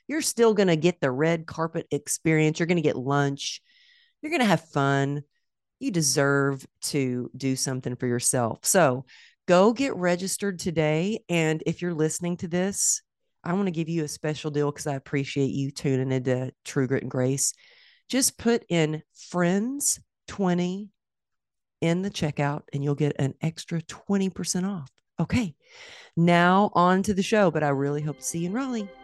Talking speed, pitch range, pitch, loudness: 175 wpm, 140-195 Hz, 165 Hz, -25 LUFS